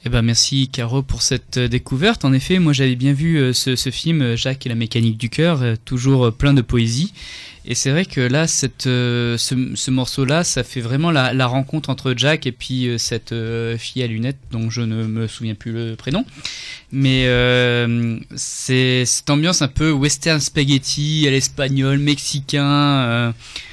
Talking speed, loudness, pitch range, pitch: 180 wpm, -18 LUFS, 120-140 Hz, 130 Hz